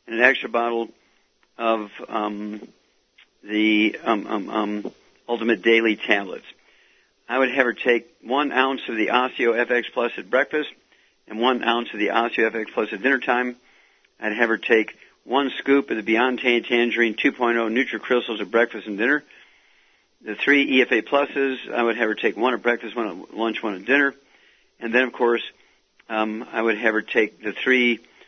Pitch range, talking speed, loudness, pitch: 110-130 Hz, 180 wpm, -22 LUFS, 120 Hz